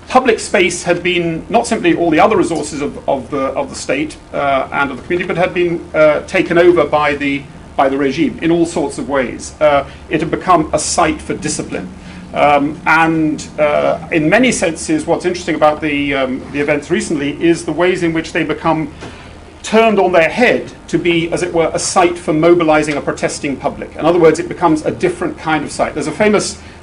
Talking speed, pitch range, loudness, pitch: 210 wpm, 150-175 Hz, -14 LUFS, 165 Hz